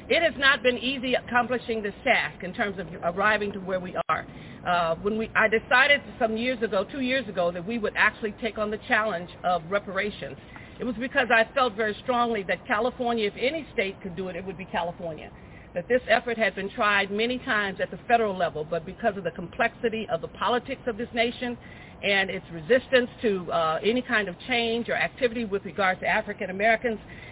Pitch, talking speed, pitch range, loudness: 215 Hz, 210 wpm, 185-240 Hz, -26 LUFS